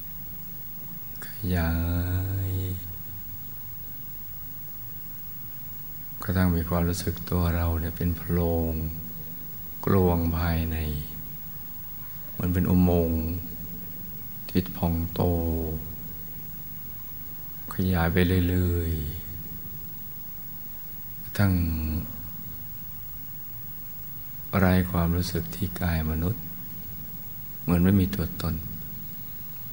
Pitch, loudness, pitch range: 90 Hz, -29 LUFS, 85-95 Hz